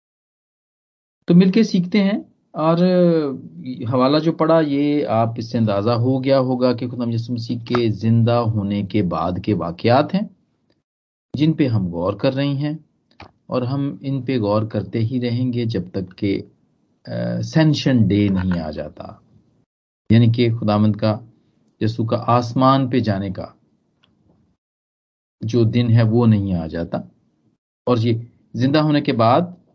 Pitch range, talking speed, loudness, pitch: 110-140 Hz, 145 wpm, -19 LUFS, 120 Hz